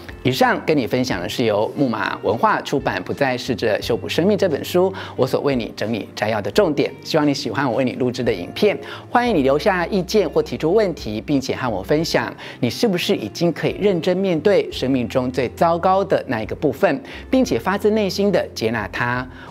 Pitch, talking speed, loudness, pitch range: 170 Hz, 315 characters per minute, -20 LUFS, 135-200 Hz